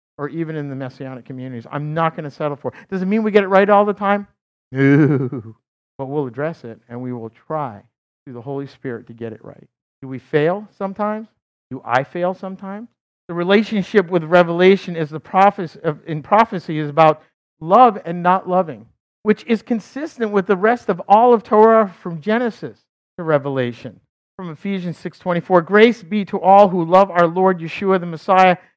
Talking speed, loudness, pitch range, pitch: 190 wpm, -17 LUFS, 140-200 Hz, 175 Hz